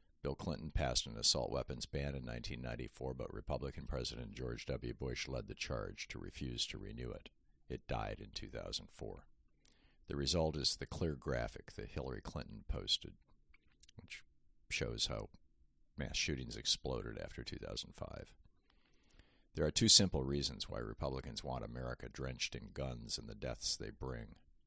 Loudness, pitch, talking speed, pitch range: -40 LUFS, 70 Hz, 150 wpm, 65-75 Hz